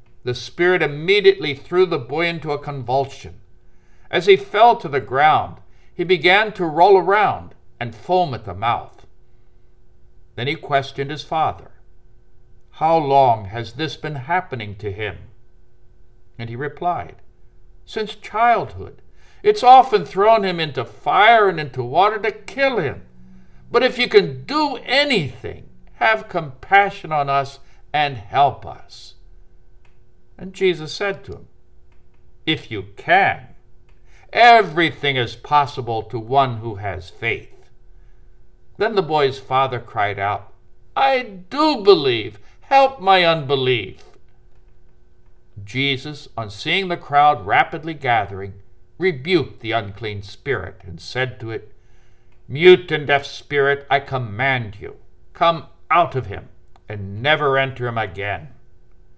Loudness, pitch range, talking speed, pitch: -18 LUFS, 115-180 Hz, 130 wpm, 140 Hz